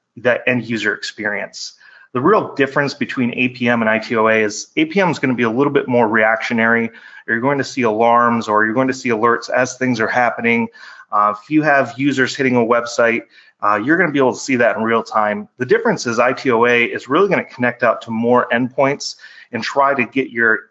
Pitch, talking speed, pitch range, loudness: 120 Hz, 215 wpm, 115-130 Hz, -16 LUFS